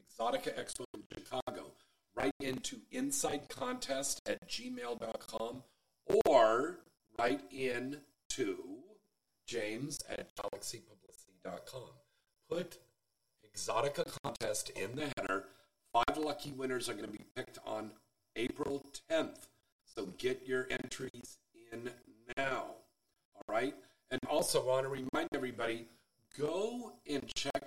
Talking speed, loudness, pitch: 115 wpm, -38 LUFS, 145 Hz